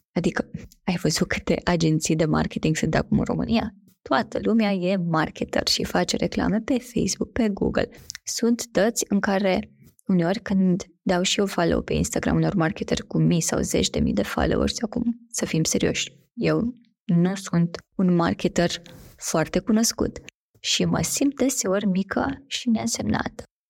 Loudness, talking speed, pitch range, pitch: -24 LUFS, 155 wpm, 170-225 Hz, 195 Hz